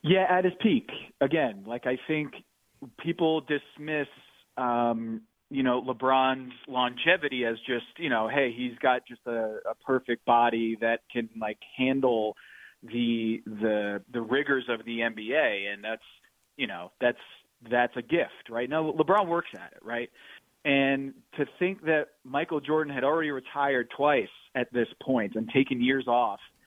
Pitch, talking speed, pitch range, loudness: 125 Hz, 160 wpm, 115-145 Hz, -28 LUFS